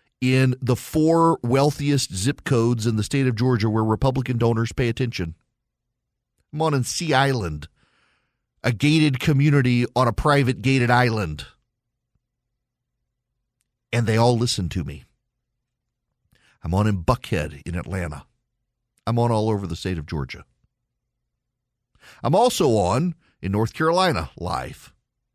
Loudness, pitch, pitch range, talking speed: -21 LUFS, 120 Hz, 105-130 Hz, 135 wpm